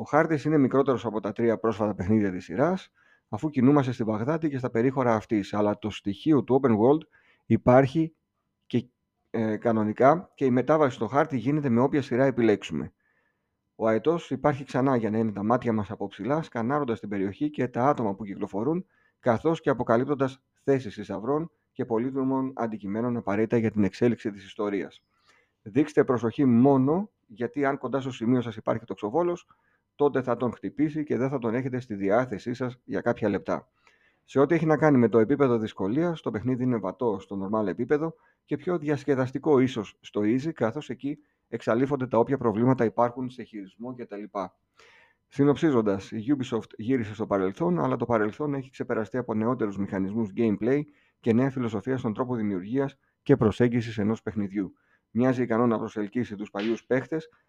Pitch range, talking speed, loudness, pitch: 110-140 Hz, 170 wpm, -26 LUFS, 120 Hz